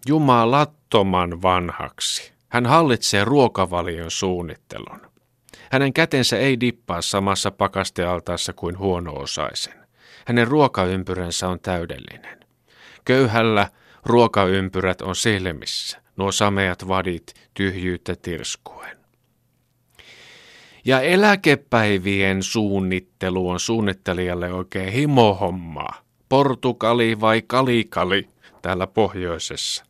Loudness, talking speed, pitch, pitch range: -20 LUFS, 80 wpm, 100 Hz, 90-120 Hz